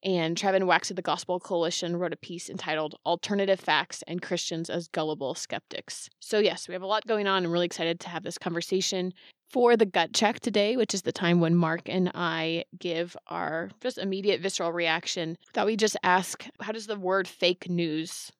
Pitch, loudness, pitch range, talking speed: 180 Hz, -28 LUFS, 170-195 Hz, 200 wpm